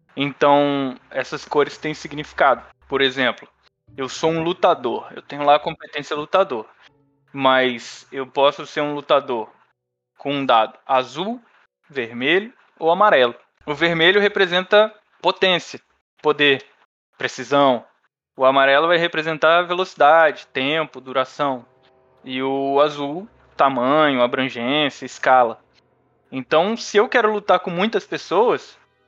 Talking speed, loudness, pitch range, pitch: 120 wpm, -19 LUFS, 130-170 Hz, 145 Hz